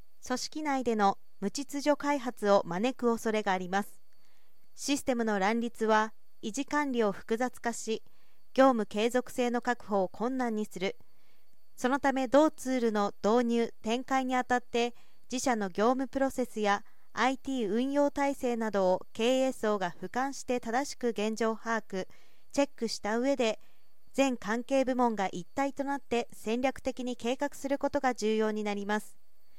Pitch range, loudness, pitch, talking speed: 215-265 Hz, -31 LUFS, 240 Hz, 285 characters per minute